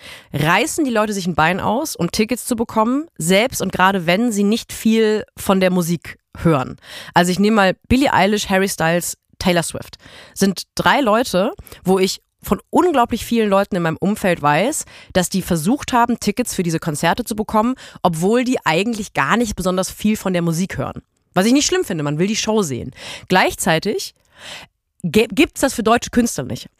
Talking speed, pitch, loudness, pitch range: 190 wpm, 200 Hz, -18 LUFS, 180-235 Hz